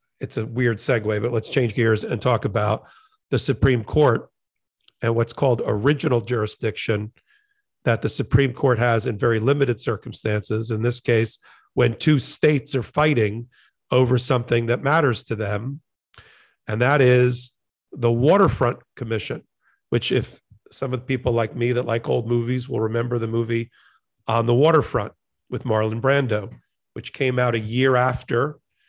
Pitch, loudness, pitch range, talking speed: 120 Hz, -21 LUFS, 115-130 Hz, 160 wpm